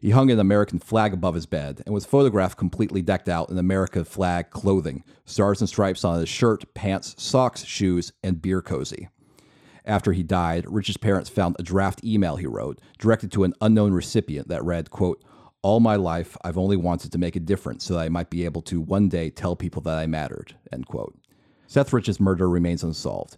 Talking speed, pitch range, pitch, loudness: 205 wpm, 85-105 Hz, 95 Hz, -24 LUFS